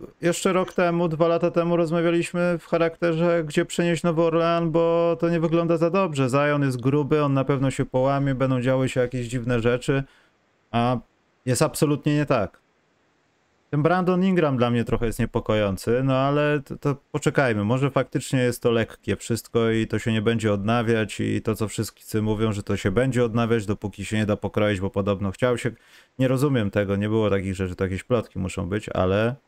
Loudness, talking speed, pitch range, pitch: -23 LUFS, 195 wpm, 110-160 Hz, 130 Hz